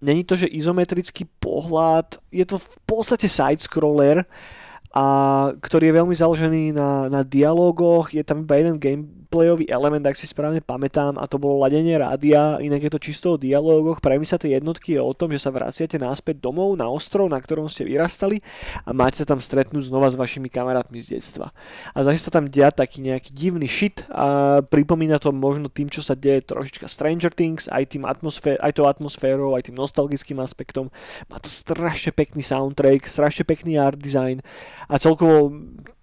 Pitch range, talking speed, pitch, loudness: 135-160 Hz, 185 wpm, 145 Hz, -20 LUFS